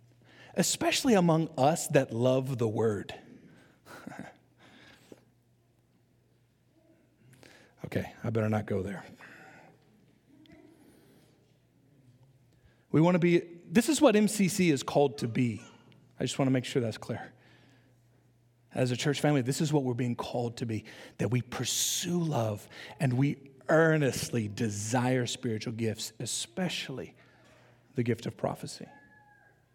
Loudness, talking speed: -29 LUFS, 120 wpm